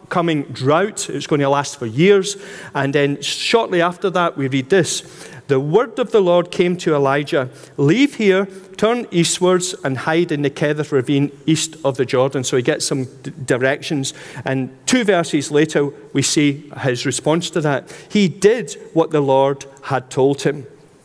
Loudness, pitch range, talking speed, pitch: -18 LUFS, 140-180 Hz, 175 wpm, 150 Hz